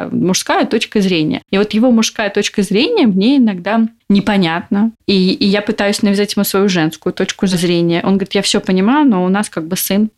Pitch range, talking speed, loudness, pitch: 190-220 Hz, 195 wpm, -14 LUFS, 205 Hz